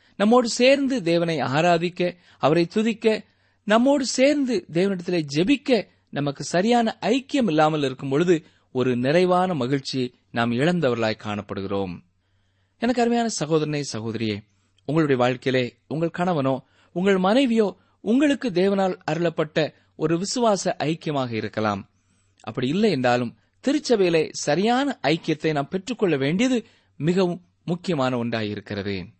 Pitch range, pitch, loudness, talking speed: 125-200 Hz, 165 Hz, -23 LUFS, 105 wpm